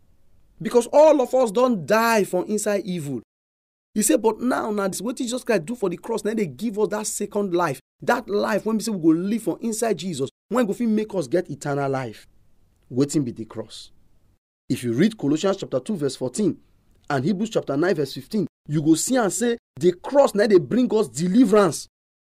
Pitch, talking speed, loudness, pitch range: 195 Hz, 210 wpm, -22 LUFS, 140-220 Hz